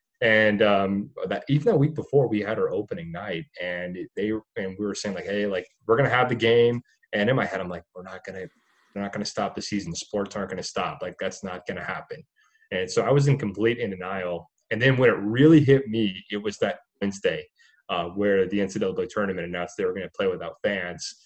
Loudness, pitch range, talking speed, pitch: -25 LUFS, 100-145 Hz, 230 wpm, 110 Hz